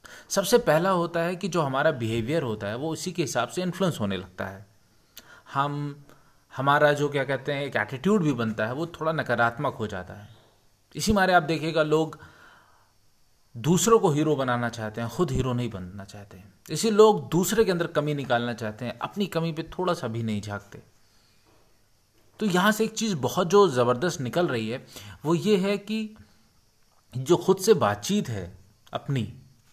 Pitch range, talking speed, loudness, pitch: 110-175 Hz, 180 wpm, -25 LUFS, 140 Hz